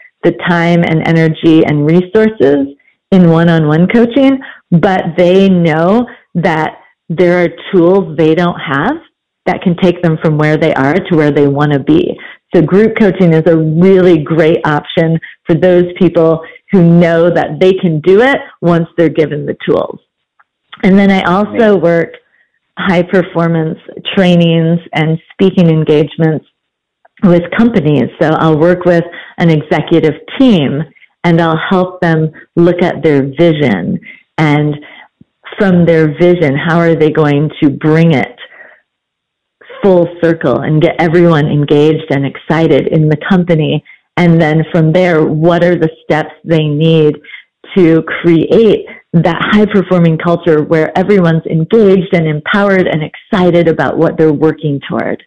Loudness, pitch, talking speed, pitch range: -10 LUFS, 170 Hz, 150 wpm, 155-180 Hz